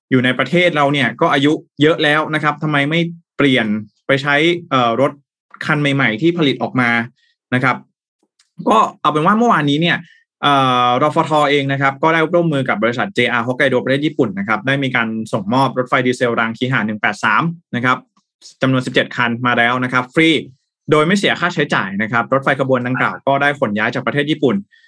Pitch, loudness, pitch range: 135 Hz, -15 LUFS, 125-155 Hz